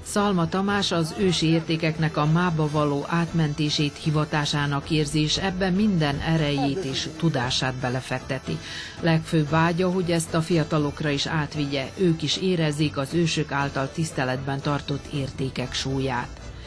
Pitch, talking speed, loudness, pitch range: 155 Hz, 125 wpm, -24 LUFS, 140-165 Hz